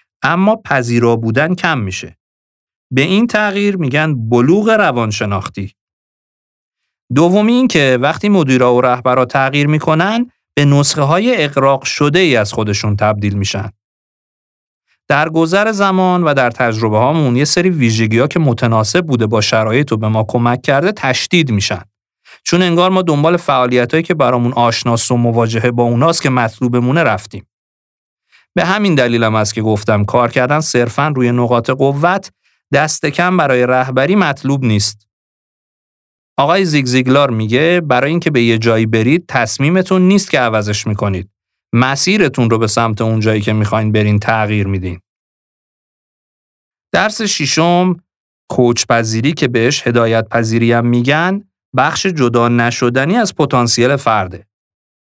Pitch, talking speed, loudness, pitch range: 125 Hz, 135 wpm, -13 LUFS, 110-160 Hz